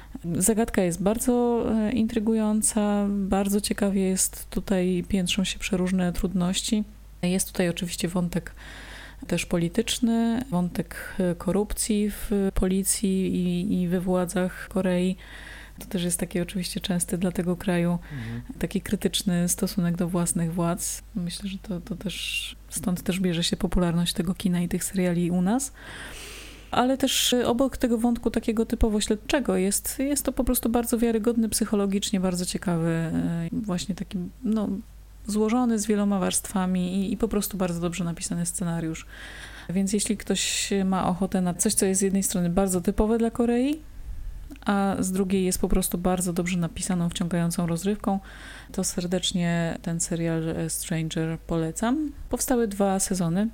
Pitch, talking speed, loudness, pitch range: 190 Hz, 145 wpm, -26 LUFS, 180-215 Hz